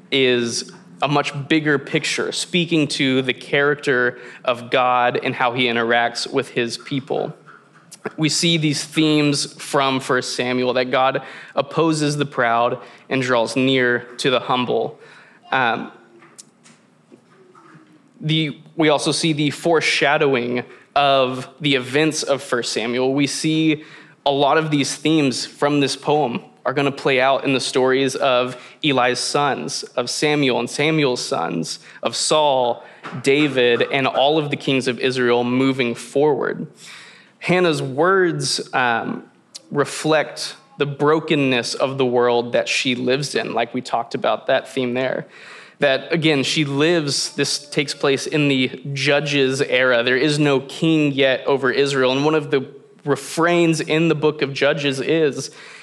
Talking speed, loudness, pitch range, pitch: 145 wpm, -19 LUFS, 125-150 Hz, 140 Hz